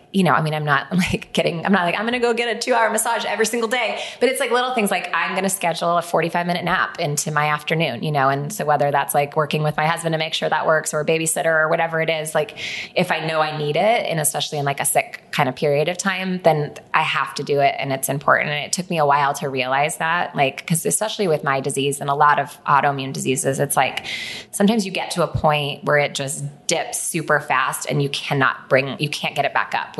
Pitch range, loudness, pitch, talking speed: 145-185 Hz, -20 LUFS, 155 Hz, 270 wpm